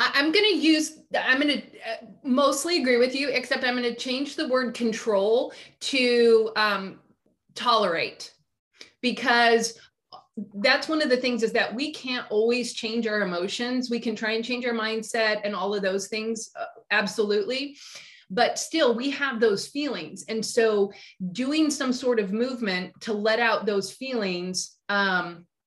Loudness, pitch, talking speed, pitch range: -24 LUFS, 235 Hz, 160 wpm, 215-260 Hz